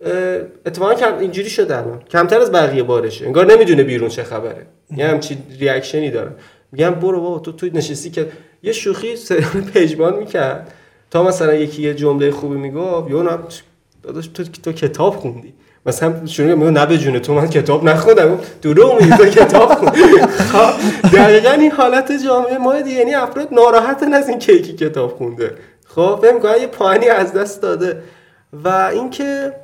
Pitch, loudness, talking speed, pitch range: 180 Hz, -13 LUFS, 160 wpm, 155-255 Hz